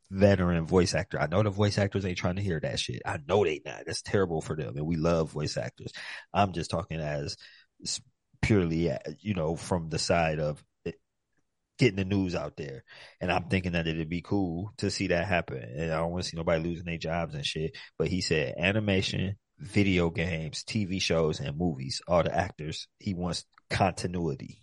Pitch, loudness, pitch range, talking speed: 90 Hz, -30 LUFS, 85-100 Hz, 200 wpm